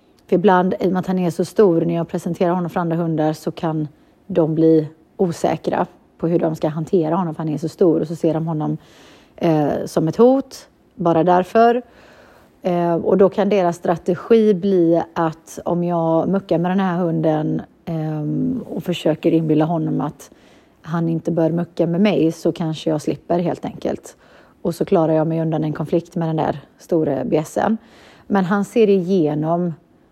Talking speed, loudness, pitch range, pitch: 185 wpm, -19 LUFS, 160-185 Hz, 170 Hz